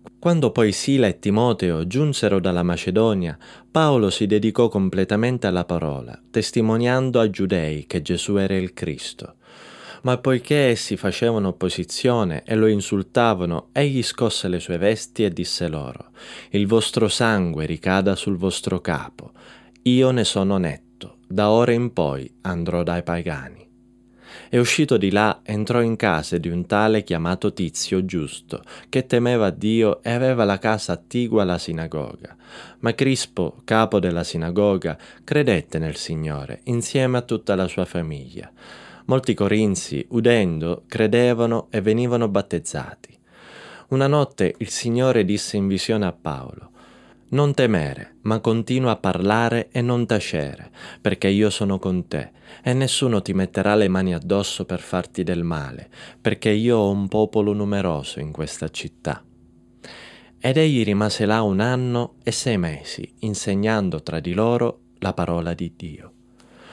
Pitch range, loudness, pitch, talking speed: 90-120 Hz, -21 LUFS, 105 Hz, 145 wpm